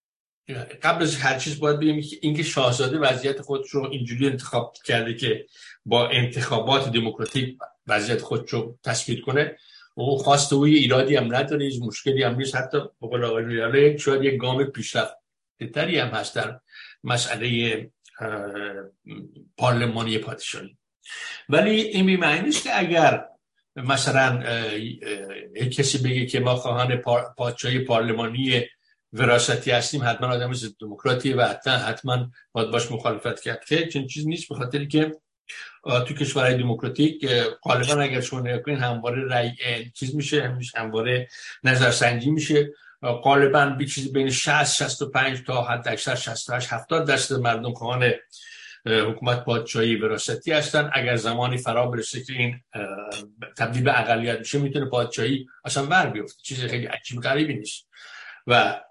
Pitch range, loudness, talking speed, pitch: 120-140 Hz, -23 LUFS, 145 wpm, 125 Hz